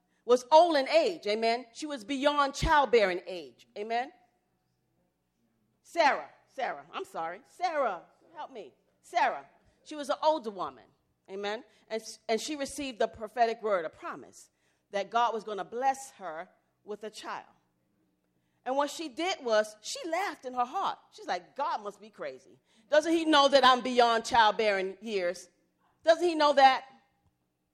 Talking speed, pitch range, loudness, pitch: 155 wpm, 210-290 Hz, -29 LUFS, 235 Hz